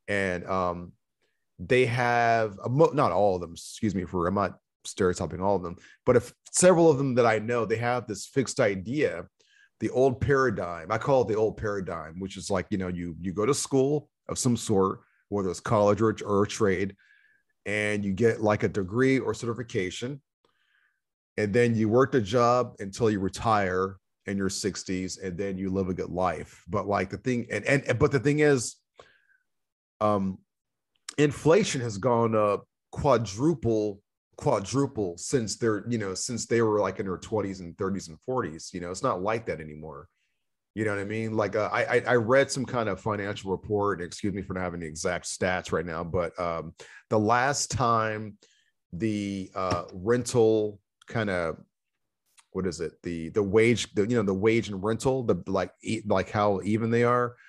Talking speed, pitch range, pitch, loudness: 190 wpm, 95-120 Hz, 105 Hz, -27 LUFS